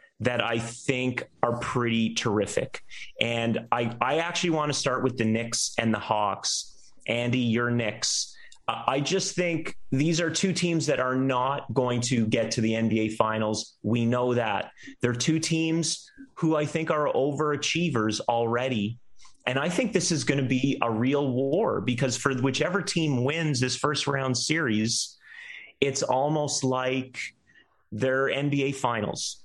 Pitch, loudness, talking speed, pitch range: 130 Hz, -26 LUFS, 155 wpm, 115-150 Hz